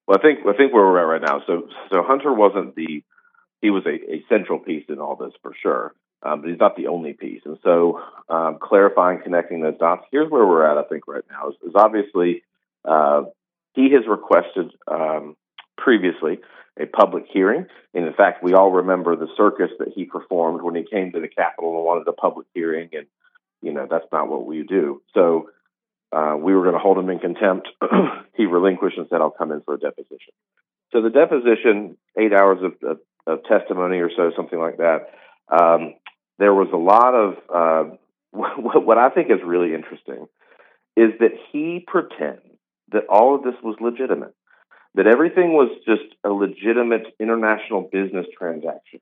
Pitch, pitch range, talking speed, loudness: 100 Hz, 85-125 Hz, 190 wpm, -19 LUFS